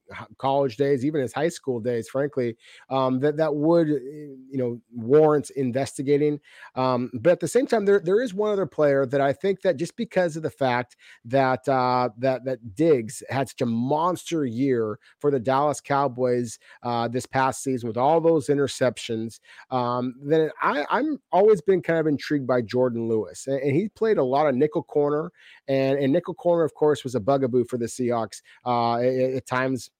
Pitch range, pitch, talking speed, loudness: 125-155 Hz, 135 Hz, 190 wpm, -24 LUFS